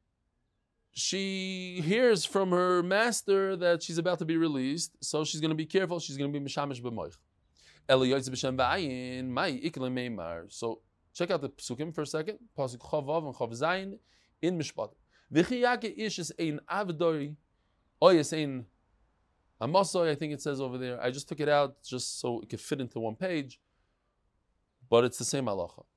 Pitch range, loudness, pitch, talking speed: 125-175 Hz, -31 LUFS, 150 Hz, 160 wpm